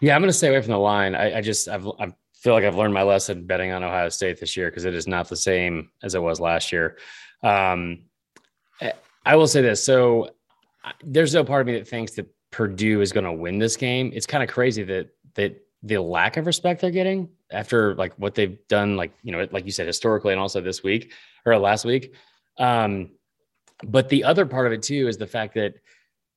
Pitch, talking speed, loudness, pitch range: 110 Hz, 230 wpm, -22 LUFS, 95-130 Hz